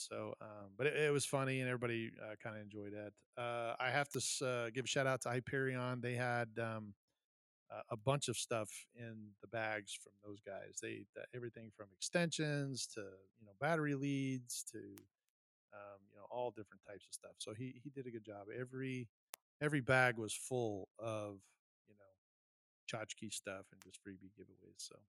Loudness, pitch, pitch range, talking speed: -42 LUFS, 120 Hz, 105-130 Hz, 190 wpm